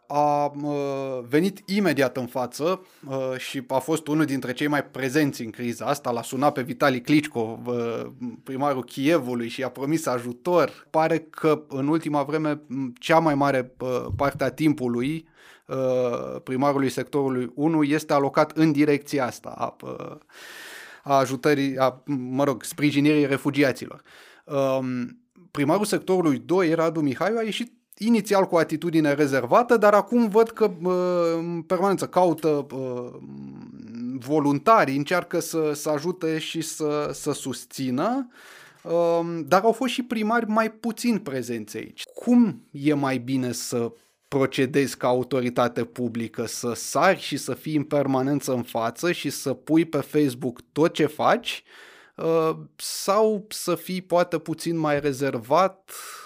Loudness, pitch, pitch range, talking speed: -24 LUFS, 145 Hz, 130-165 Hz, 130 wpm